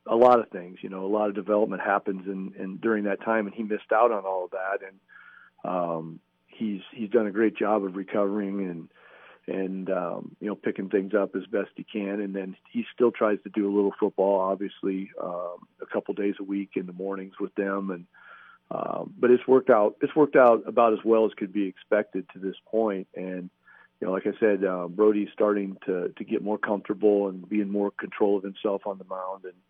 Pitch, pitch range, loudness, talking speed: 100 Hz, 95-105 Hz, -26 LUFS, 230 wpm